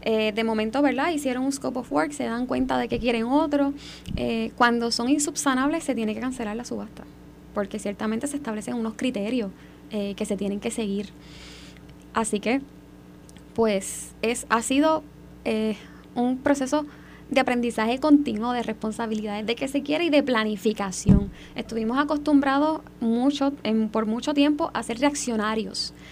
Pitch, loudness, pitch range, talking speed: 235 Hz, -25 LUFS, 215-275 Hz, 160 wpm